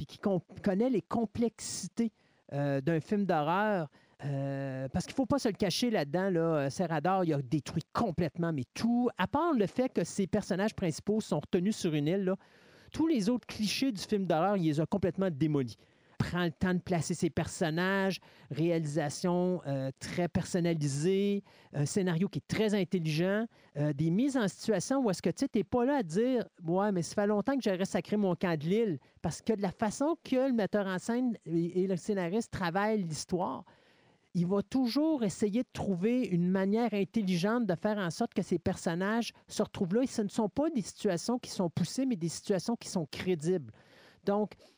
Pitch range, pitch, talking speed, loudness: 170-215 Hz, 190 Hz, 200 wpm, -32 LUFS